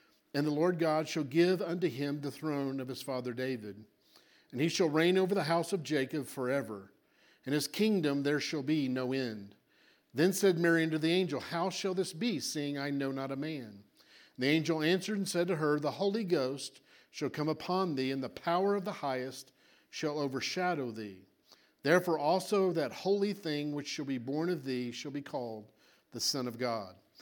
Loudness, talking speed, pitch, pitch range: -33 LUFS, 200 wpm, 150 Hz, 130-175 Hz